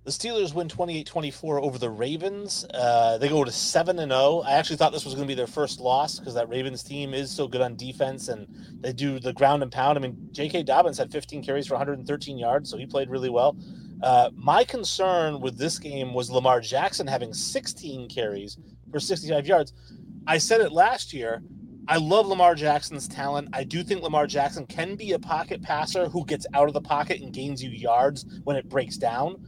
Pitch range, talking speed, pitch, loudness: 130-170 Hz, 215 wpm, 145 Hz, -25 LUFS